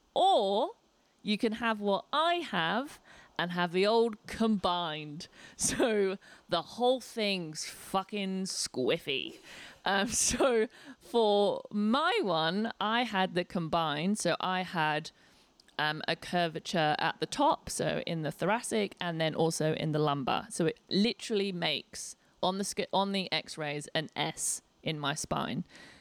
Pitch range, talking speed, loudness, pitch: 165-220 Hz, 140 wpm, -31 LUFS, 190 Hz